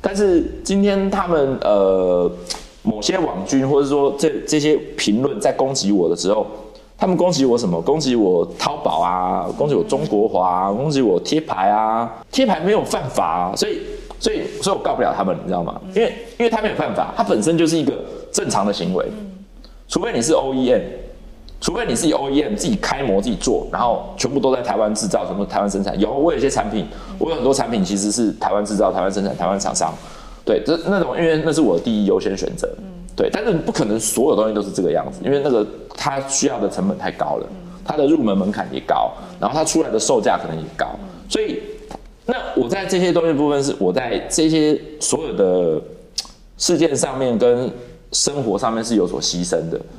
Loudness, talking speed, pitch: -19 LUFS, 310 characters per minute, 155 Hz